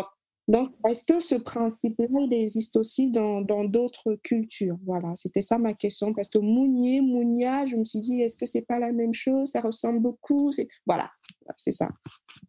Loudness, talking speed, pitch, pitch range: -26 LUFS, 190 wpm, 230 Hz, 215-250 Hz